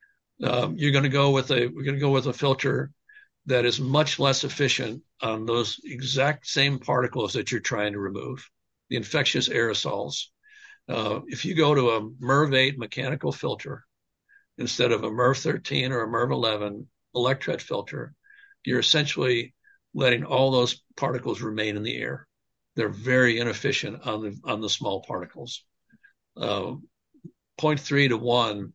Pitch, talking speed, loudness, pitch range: 130 Hz, 160 wpm, -25 LUFS, 120-145 Hz